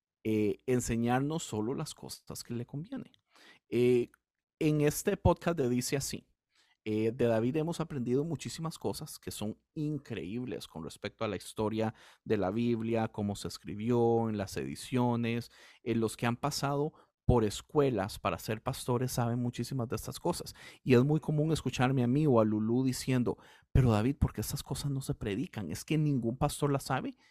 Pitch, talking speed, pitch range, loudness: 120 Hz, 180 wpm, 110-140 Hz, -32 LUFS